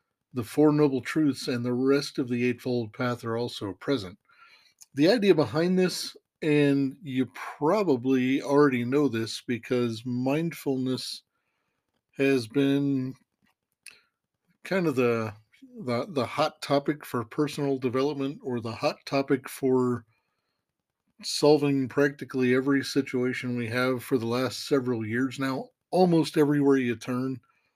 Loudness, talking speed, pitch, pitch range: -27 LUFS, 130 wpm, 135 Hz, 125-145 Hz